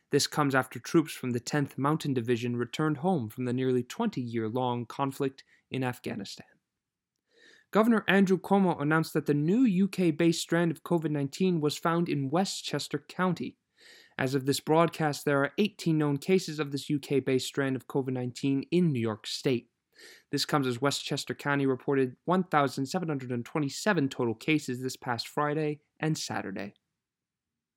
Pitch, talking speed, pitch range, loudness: 145 Hz, 160 wpm, 130-165 Hz, -29 LUFS